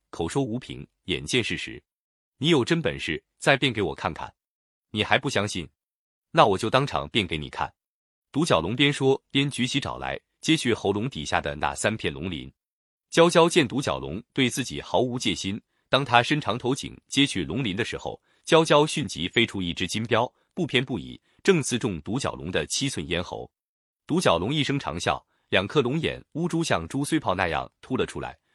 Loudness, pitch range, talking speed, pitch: -25 LUFS, 95-145 Hz, 270 characters per minute, 125 Hz